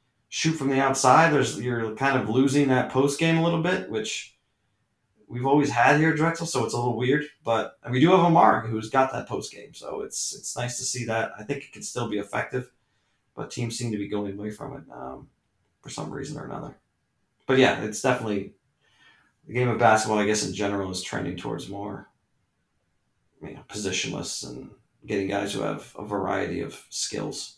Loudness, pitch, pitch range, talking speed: -25 LUFS, 125 Hz, 110-140 Hz, 205 wpm